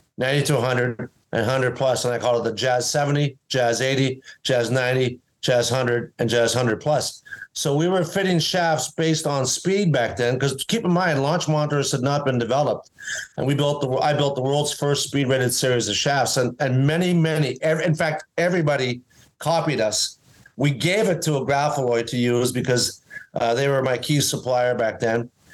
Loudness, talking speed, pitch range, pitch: -21 LUFS, 195 wpm, 125-150 Hz, 135 Hz